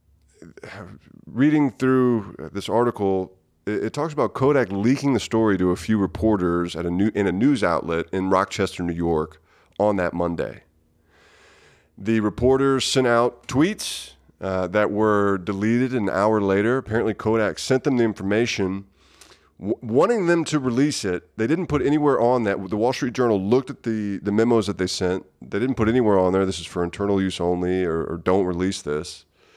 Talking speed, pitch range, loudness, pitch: 180 wpm, 90-120 Hz, -22 LUFS, 100 Hz